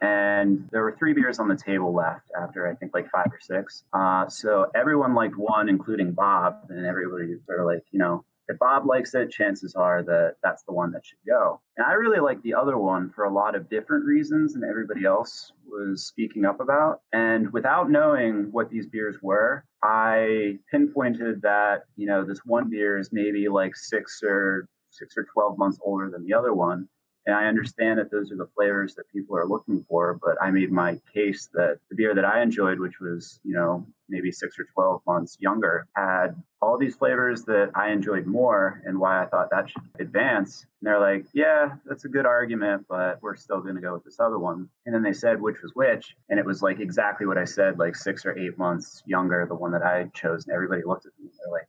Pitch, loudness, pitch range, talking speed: 100 Hz, -25 LUFS, 90-110 Hz, 225 wpm